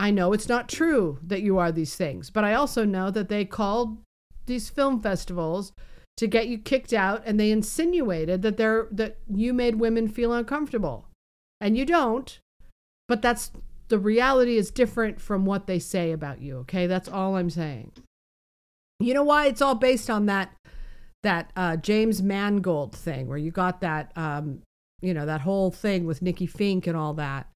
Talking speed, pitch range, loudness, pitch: 185 wpm, 170-230 Hz, -25 LUFS, 200 Hz